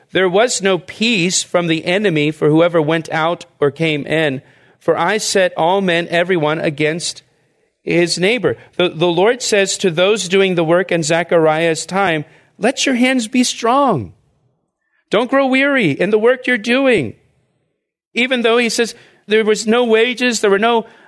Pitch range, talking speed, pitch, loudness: 165-230 Hz, 170 wpm, 185 Hz, -15 LUFS